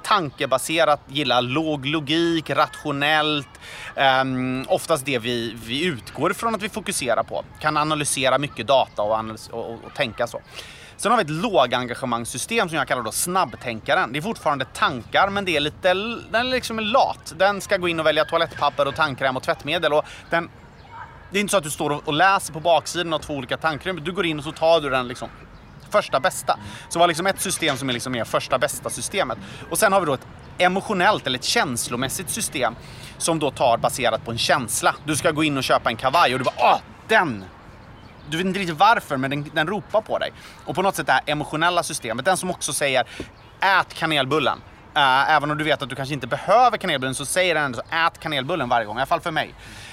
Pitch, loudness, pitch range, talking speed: 150 Hz, -21 LUFS, 130-175 Hz, 220 wpm